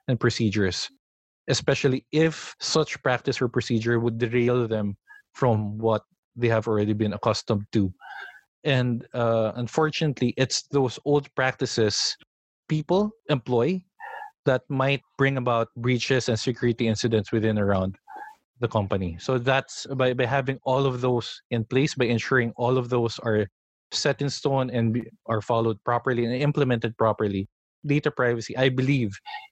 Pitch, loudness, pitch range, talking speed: 125 Hz, -25 LUFS, 115-135 Hz, 145 wpm